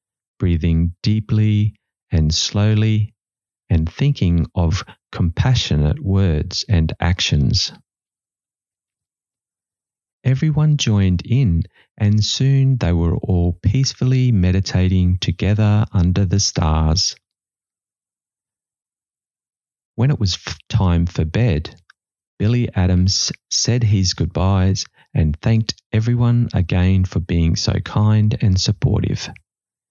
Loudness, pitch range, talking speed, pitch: -18 LUFS, 90-115 Hz, 90 wpm, 100 Hz